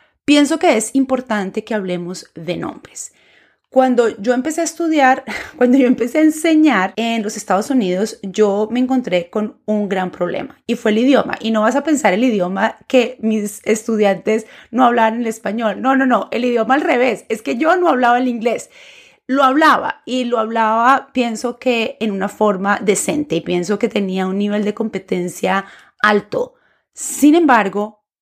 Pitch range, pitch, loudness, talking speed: 210-260 Hz, 230 Hz, -16 LUFS, 175 wpm